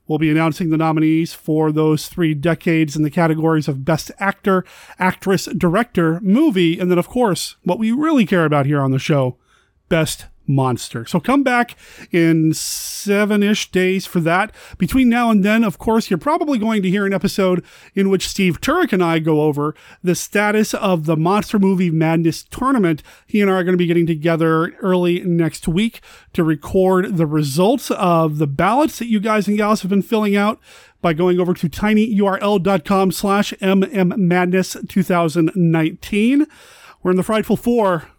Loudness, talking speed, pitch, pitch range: -17 LUFS, 175 wpm, 185 Hz, 165-205 Hz